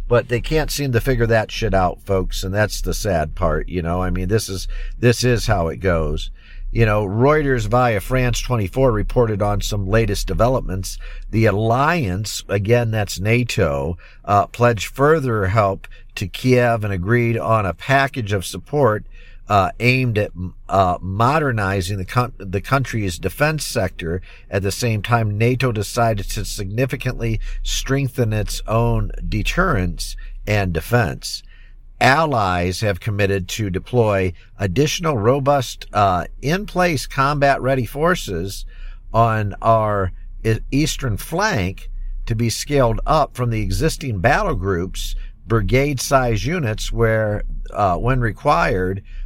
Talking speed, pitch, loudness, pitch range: 135 wpm, 110 Hz, -19 LUFS, 95-125 Hz